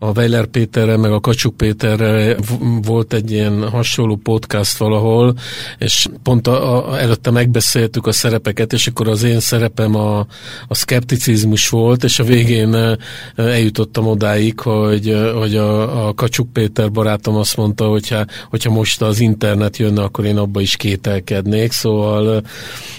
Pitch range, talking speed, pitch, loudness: 105-120 Hz, 145 wpm, 110 Hz, -15 LUFS